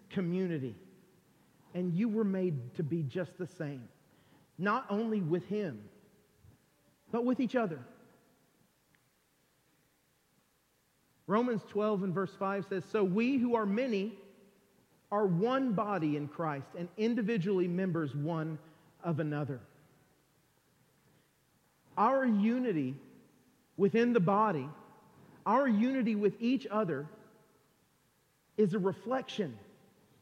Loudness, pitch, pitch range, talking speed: -33 LUFS, 195 Hz, 160-220 Hz, 105 wpm